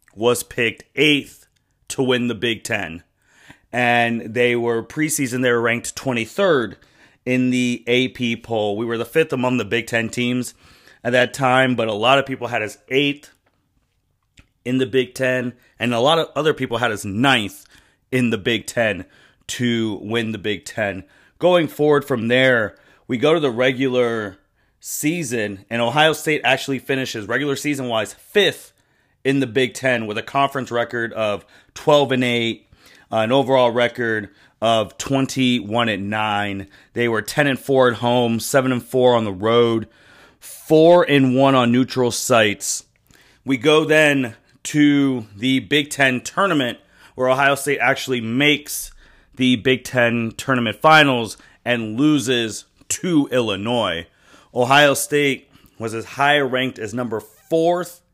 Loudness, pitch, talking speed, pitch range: -19 LUFS, 125 Hz, 155 wpm, 115-135 Hz